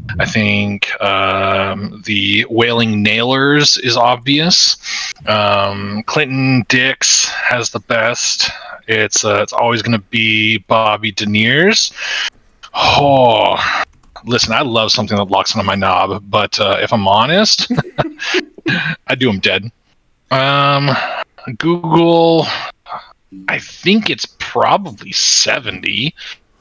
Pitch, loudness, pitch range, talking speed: 120 Hz, -13 LUFS, 105-145 Hz, 110 wpm